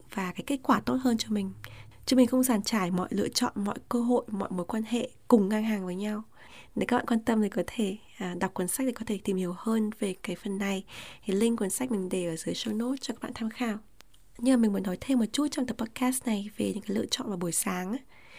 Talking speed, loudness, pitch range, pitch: 275 wpm, -29 LUFS, 195-245 Hz, 215 Hz